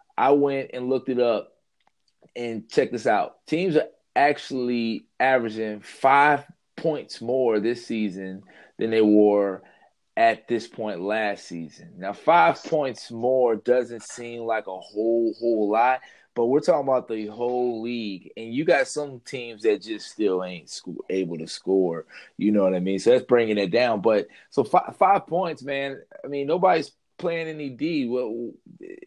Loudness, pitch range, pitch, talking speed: -24 LUFS, 105-140 Hz, 120 Hz, 170 wpm